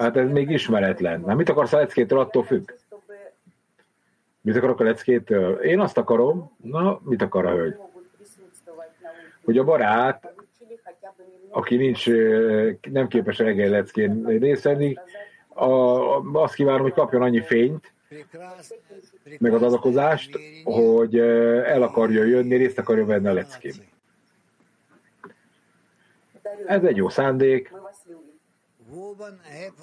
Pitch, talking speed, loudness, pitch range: 145 Hz, 115 wpm, -21 LUFS, 120-190 Hz